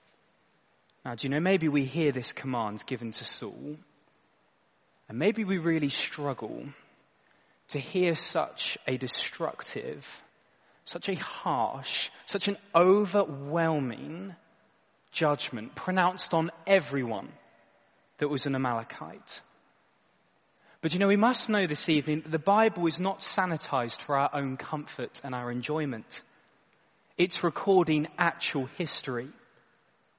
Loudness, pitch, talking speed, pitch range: -29 LUFS, 155 Hz, 120 wpm, 135-185 Hz